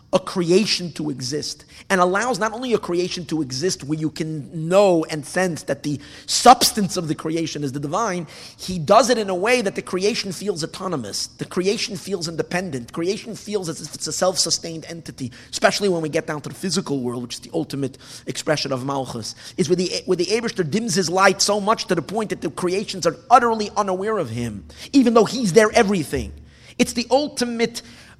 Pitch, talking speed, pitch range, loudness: 180 Hz, 205 wpm, 155-205 Hz, -21 LUFS